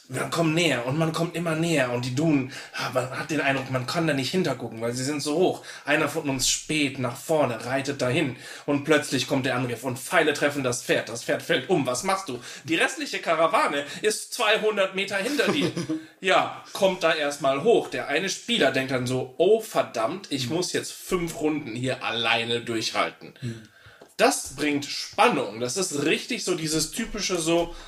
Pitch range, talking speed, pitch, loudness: 130-170 Hz, 190 wpm, 145 Hz, -25 LUFS